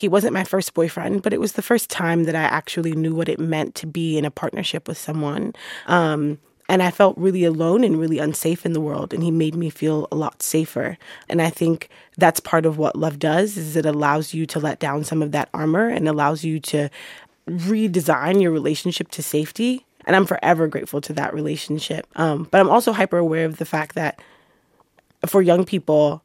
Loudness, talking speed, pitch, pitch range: -20 LUFS, 215 wpm, 160 Hz, 155-180 Hz